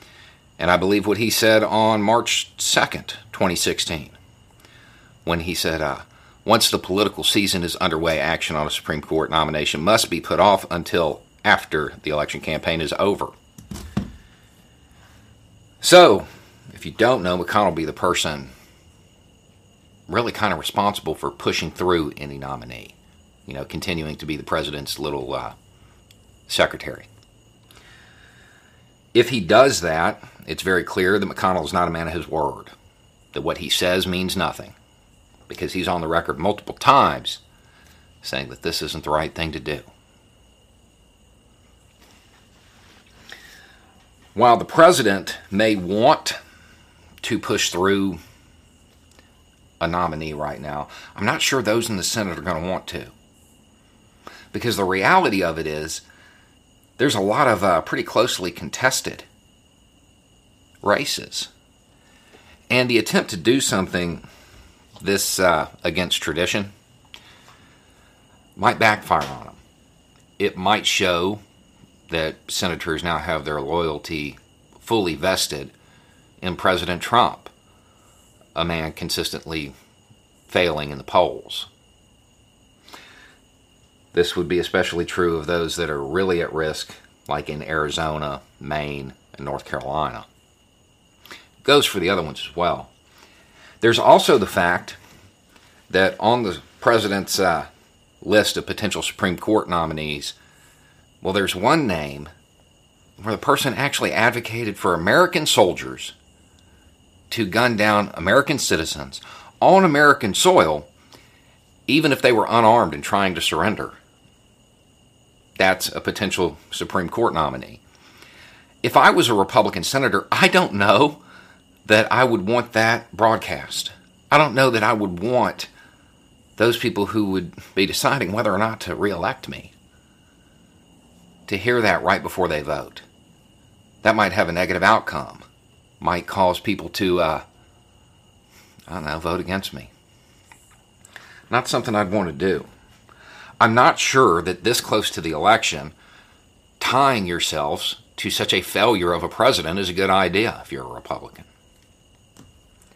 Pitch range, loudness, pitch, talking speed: 85-105 Hz, -20 LUFS, 95 Hz, 135 wpm